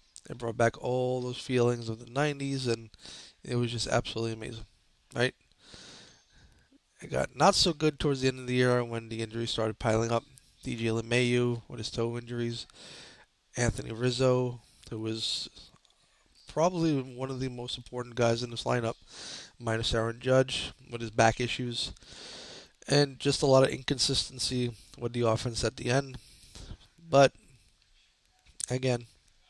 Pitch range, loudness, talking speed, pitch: 115-130 Hz, -30 LUFS, 150 wpm, 120 Hz